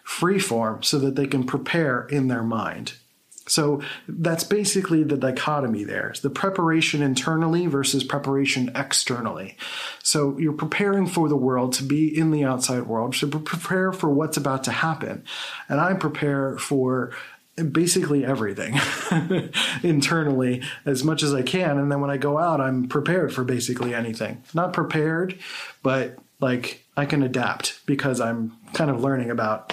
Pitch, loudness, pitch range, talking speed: 140 Hz, -23 LUFS, 130-160 Hz, 160 wpm